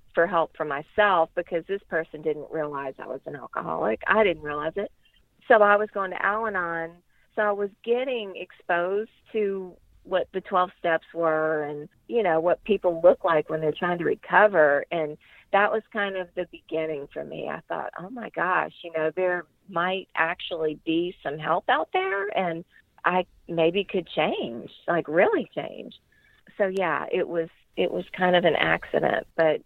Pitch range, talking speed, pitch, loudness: 160-195 Hz, 180 wpm, 175 Hz, -25 LUFS